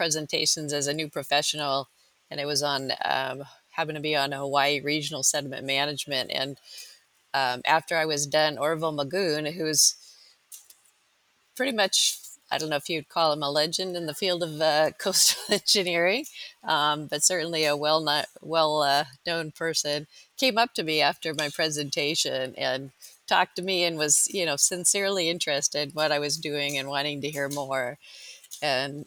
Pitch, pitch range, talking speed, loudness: 150 Hz, 145-165 Hz, 170 wpm, -25 LUFS